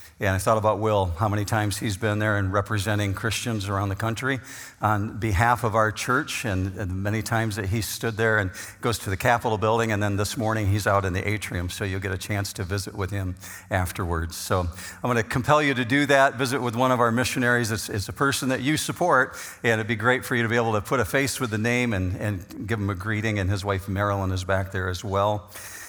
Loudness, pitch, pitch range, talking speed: -24 LUFS, 110 Hz, 100-120 Hz, 255 wpm